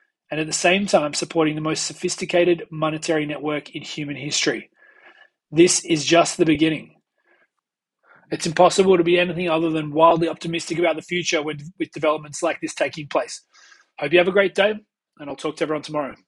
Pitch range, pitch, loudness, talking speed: 155-180 Hz, 165 Hz, -21 LUFS, 185 wpm